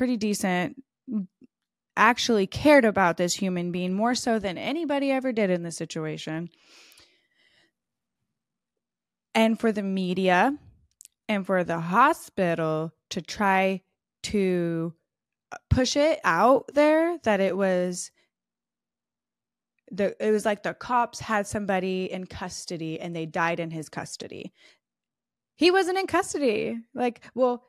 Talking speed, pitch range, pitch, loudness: 125 wpm, 180-245 Hz, 200 Hz, -25 LUFS